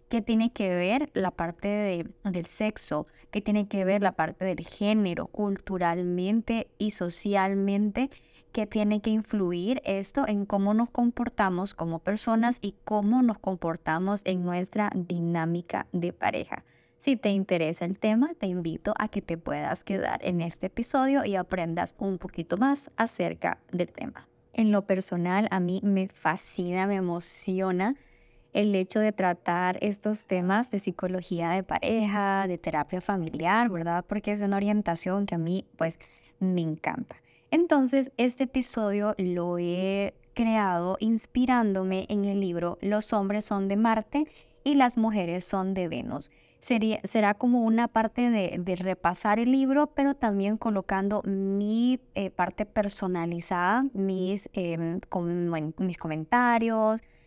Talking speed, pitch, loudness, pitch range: 145 wpm, 200 Hz, -28 LUFS, 180-220 Hz